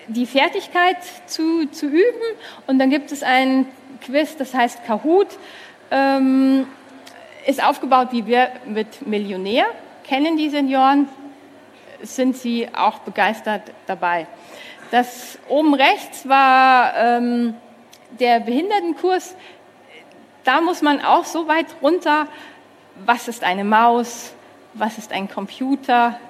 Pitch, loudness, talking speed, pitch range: 265 Hz, -18 LUFS, 115 wpm, 235-305 Hz